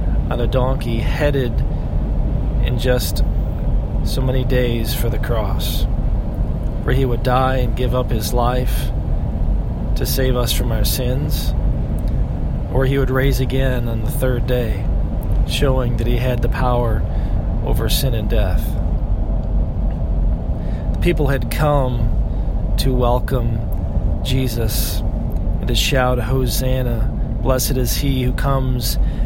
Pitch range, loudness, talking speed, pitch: 105-130 Hz, -20 LUFS, 125 wpm, 120 Hz